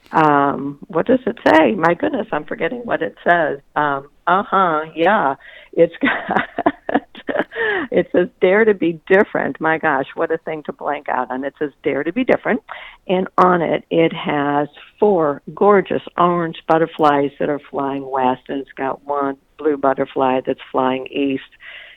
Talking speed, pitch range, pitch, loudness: 165 wpm, 140-185 Hz, 155 Hz, -18 LUFS